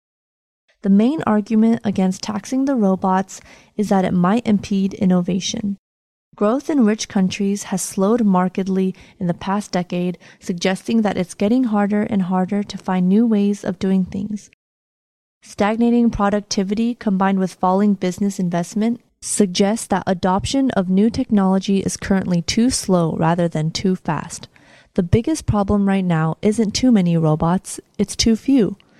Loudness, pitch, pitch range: -19 LUFS, 200 Hz, 185-215 Hz